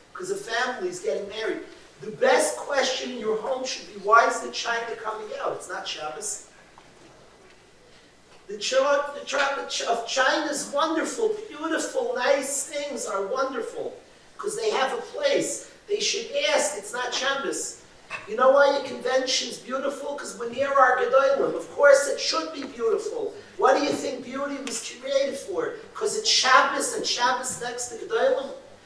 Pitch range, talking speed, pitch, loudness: 250-410 Hz, 165 wpm, 275 Hz, -25 LUFS